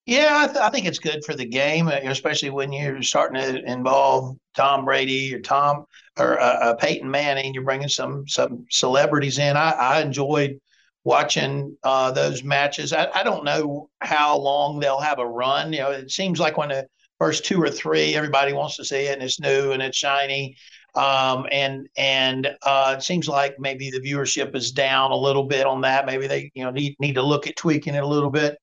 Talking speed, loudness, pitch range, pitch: 210 wpm, -21 LUFS, 135-145 Hz, 140 Hz